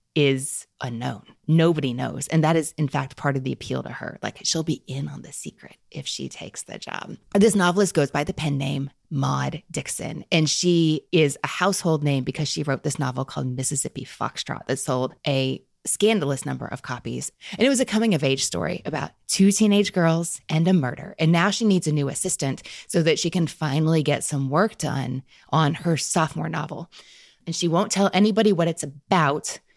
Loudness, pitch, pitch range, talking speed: -23 LUFS, 155 Hz, 140-175 Hz, 200 wpm